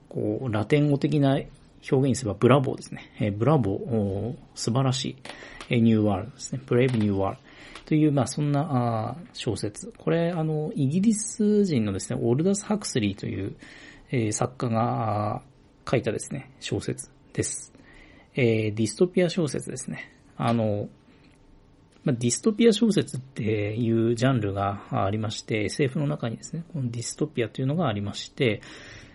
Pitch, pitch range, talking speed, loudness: 125 Hz, 110-145 Hz, 330 characters per minute, -26 LUFS